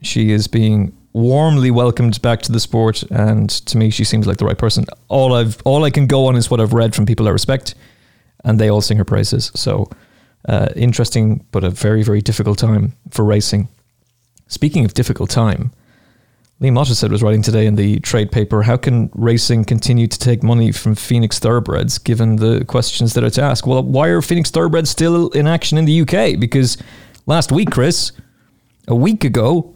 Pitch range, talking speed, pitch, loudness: 110-130 Hz, 200 wpm, 115 Hz, -15 LUFS